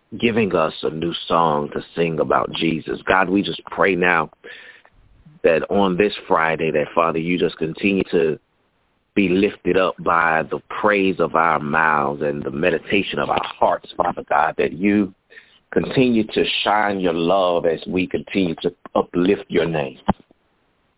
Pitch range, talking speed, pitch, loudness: 80-100 Hz, 155 wpm, 85 Hz, -20 LUFS